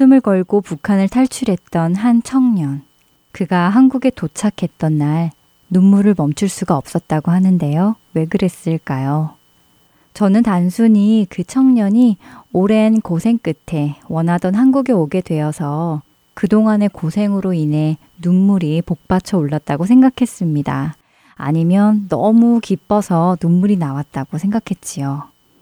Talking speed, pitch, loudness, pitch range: 275 characters per minute, 185 Hz, -15 LUFS, 160-210 Hz